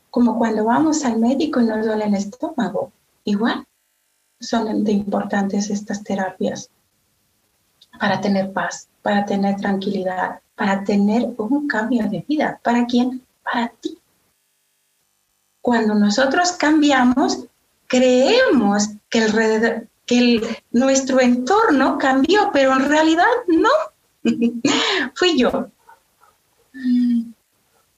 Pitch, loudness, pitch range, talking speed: 240 Hz, -18 LUFS, 215-270 Hz, 105 wpm